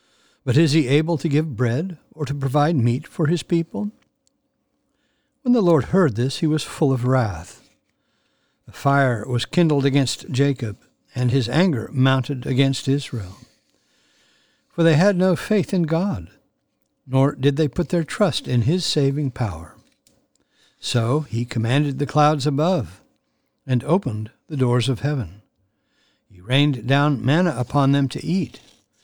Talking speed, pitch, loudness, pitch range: 150 wpm, 145 Hz, -21 LUFS, 130-170 Hz